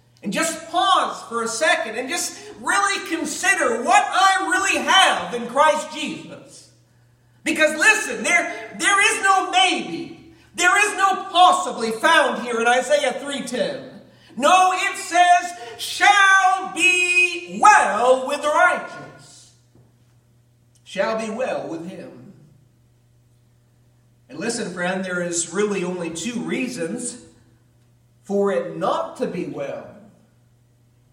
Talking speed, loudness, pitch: 120 wpm, -19 LUFS, 260 Hz